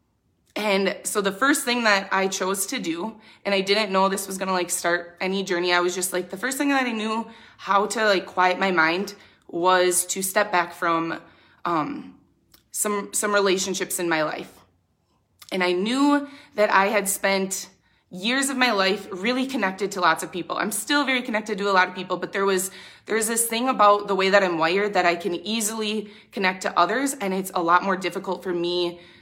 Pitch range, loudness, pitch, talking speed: 180-210 Hz, -23 LUFS, 195 Hz, 210 wpm